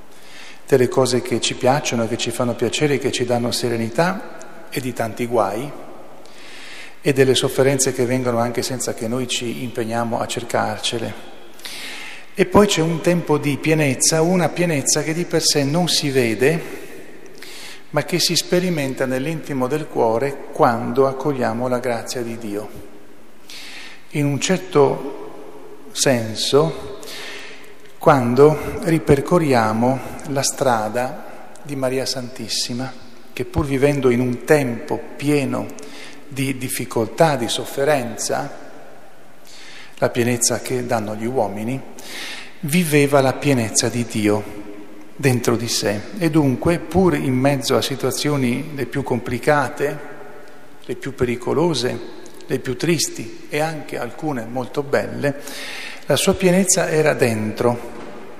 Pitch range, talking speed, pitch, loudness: 120-150 Hz, 125 wpm, 130 Hz, -19 LUFS